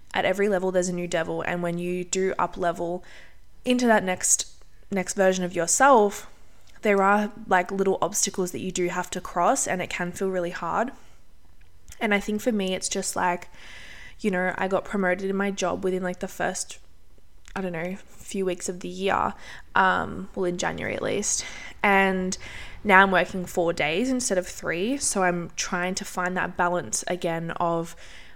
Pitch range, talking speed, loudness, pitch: 175-195 Hz, 190 wpm, -25 LUFS, 185 Hz